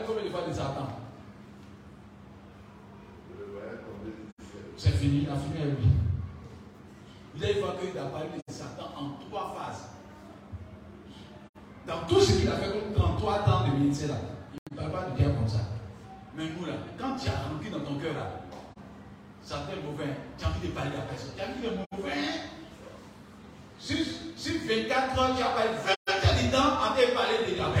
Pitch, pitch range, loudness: 120 Hz, 100-165 Hz, -30 LUFS